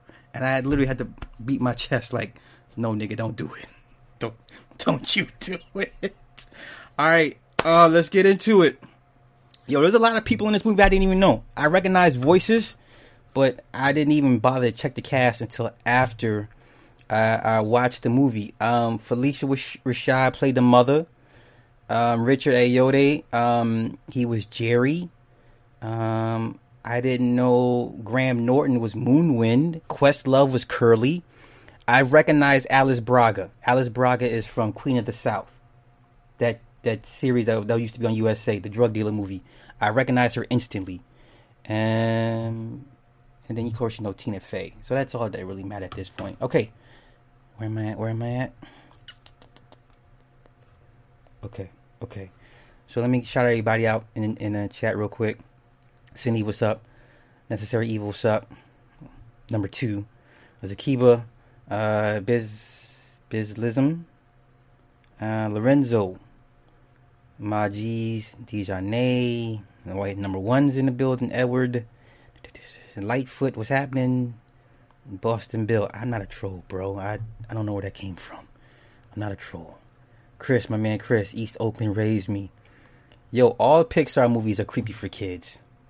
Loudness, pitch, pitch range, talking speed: -23 LUFS, 120 Hz, 110-125 Hz, 155 wpm